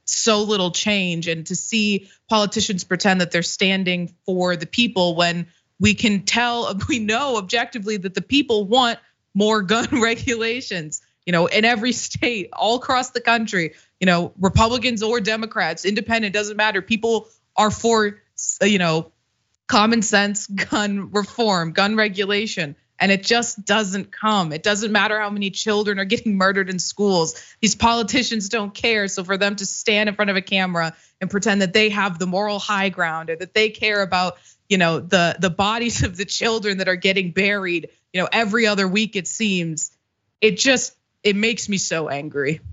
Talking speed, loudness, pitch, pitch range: 175 wpm, -20 LUFS, 200 Hz, 185-220 Hz